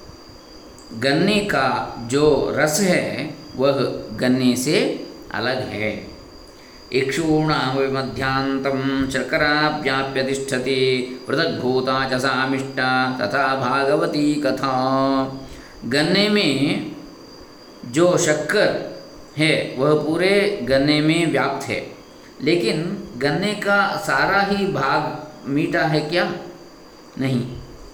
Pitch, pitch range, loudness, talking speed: 135 Hz, 130-155 Hz, -20 LUFS, 85 wpm